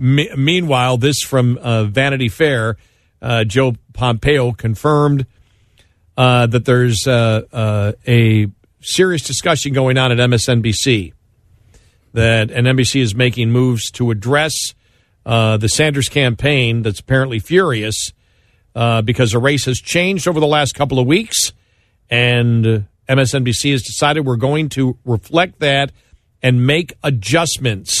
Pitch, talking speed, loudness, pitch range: 125 Hz, 130 wpm, -15 LUFS, 110-135 Hz